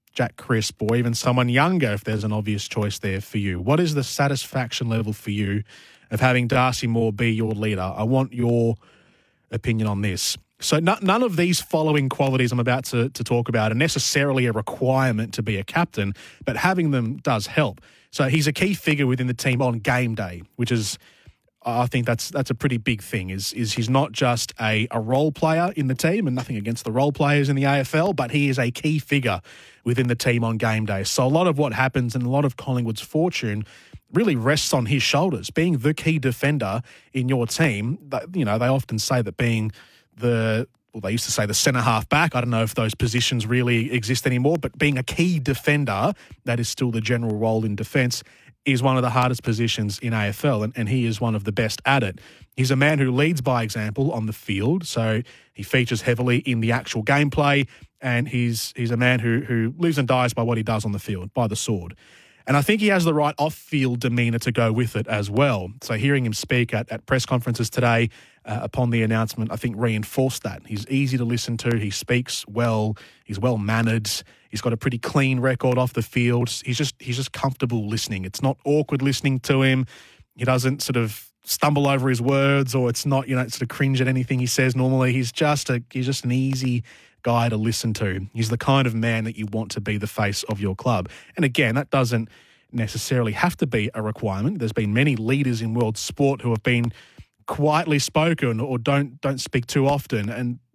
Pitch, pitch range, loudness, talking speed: 125 Hz, 115-135 Hz, -22 LUFS, 225 wpm